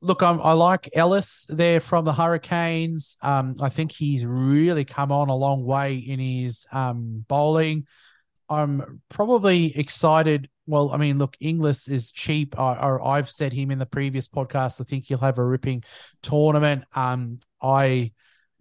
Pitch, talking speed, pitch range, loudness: 140 Hz, 160 wpm, 130-155 Hz, -23 LUFS